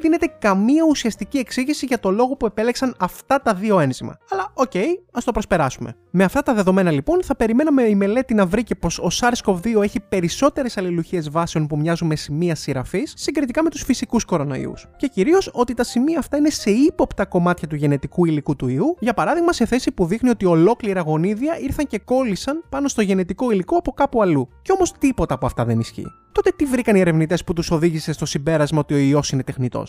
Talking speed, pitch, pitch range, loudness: 210 wpm, 205 Hz, 170-270 Hz, -19 LUFS